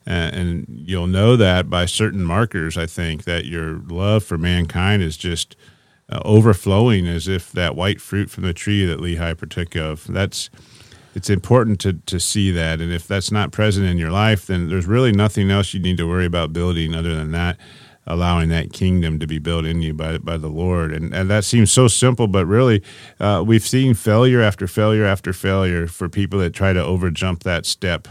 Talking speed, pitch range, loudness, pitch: 200 wpm, 85-105 Hz, -18 LUFS, 90 Hz